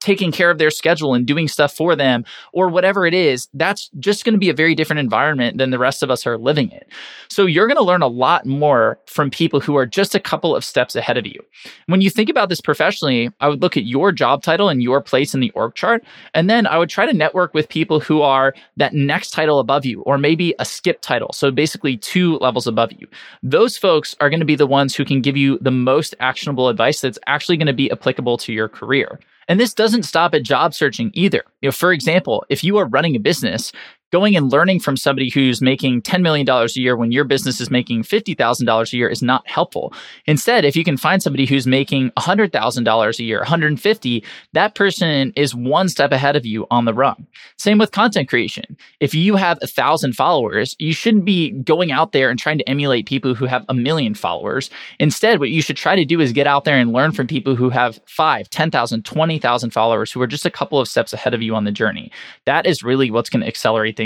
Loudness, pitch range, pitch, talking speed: -16 LUFS, 130-170 Hz, 145 Hz, 235 wpm